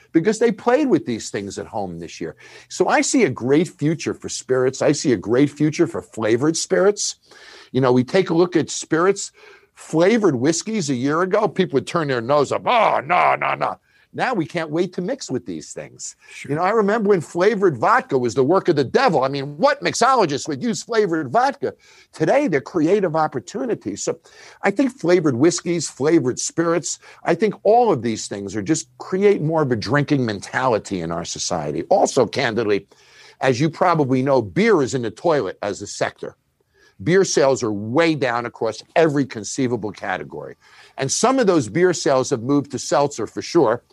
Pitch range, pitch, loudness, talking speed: 130-205 Hz, 165 Hz, -19 LUFS, 195 wpm